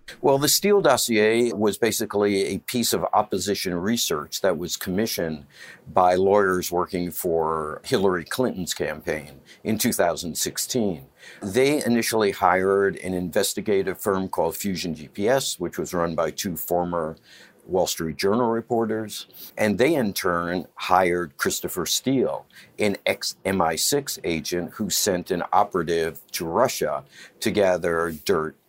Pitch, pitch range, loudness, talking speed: 95 Hz, 85-115 Hz, -23 LUFS, 130 wpm